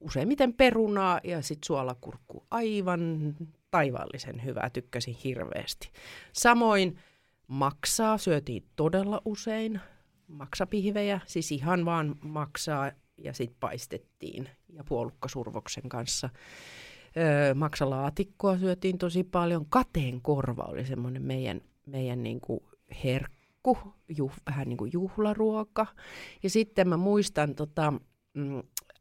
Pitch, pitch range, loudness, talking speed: 155 Hz, 135-195 Hz, -30 LUFS, 105 wpm